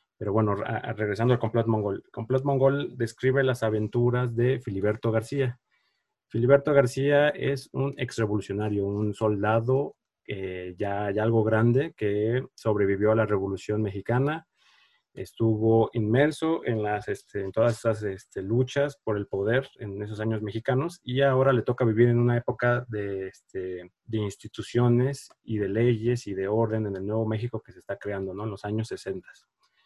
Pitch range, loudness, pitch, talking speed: 105-125 Hz, -26 LUFS, 115 Hz, 160 wpm